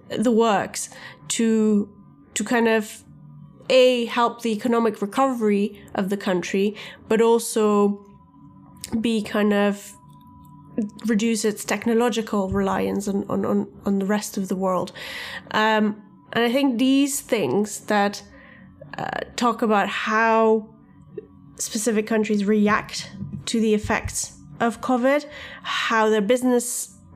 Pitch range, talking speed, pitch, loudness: 205-235 Hz, 120 wpm, 220 Hz, -22 LUFS